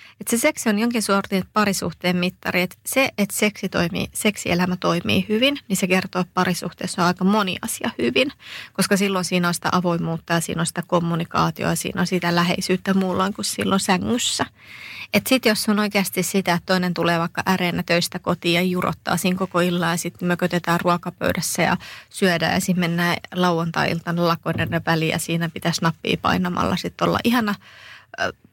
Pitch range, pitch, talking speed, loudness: 175-195 Hz, 180 Hz, 175 wpm, -21 LUFS